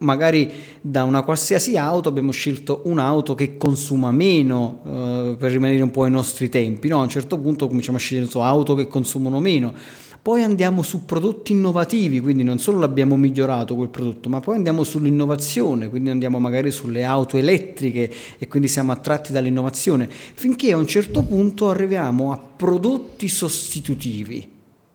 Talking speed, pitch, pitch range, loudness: 160 wpm, 140 Hz, 130-165 Hz, -20 LUFS